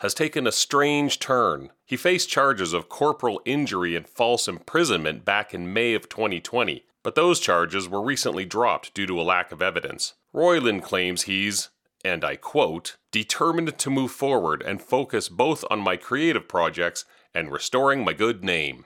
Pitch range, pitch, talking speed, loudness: 90-140 Hz, 115 Hz, 170 wpm, -24 LUFS